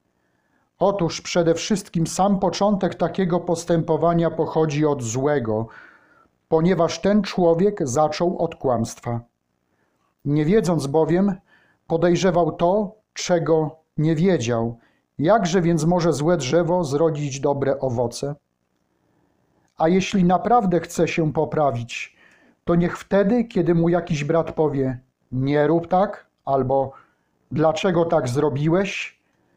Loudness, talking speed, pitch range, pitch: -21 LUFS, 110 wpm, 145-180 Hz, 165 Hz